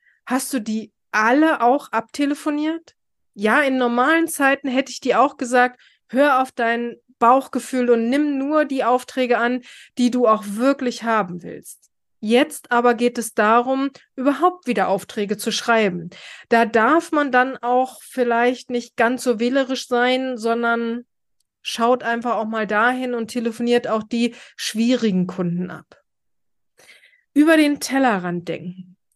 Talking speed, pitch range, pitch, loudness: 140 wpm, 230-270 Hz, 245 Hz, -19 LUFS